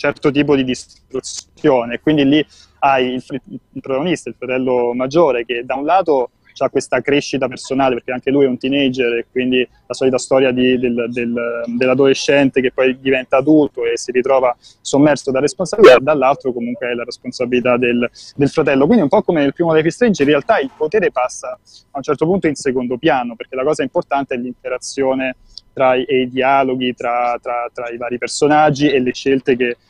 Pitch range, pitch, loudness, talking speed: 125-145 Hz, 130 Hz, -16 LUFS, 195 wpm